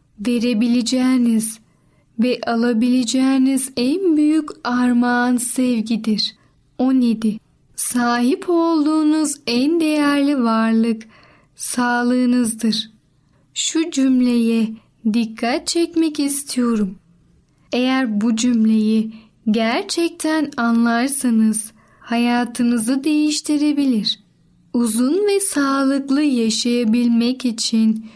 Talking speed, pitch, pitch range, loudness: 65 wpm, 245 Hz, 225-275 Hz, -18 LUFS